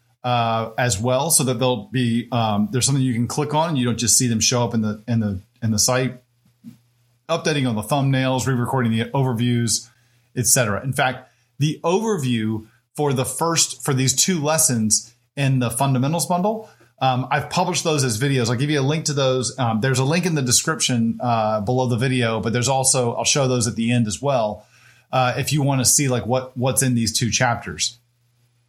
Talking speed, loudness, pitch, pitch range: 210 wpm, -20 LUFS, 125 Hz, 120-135 Hz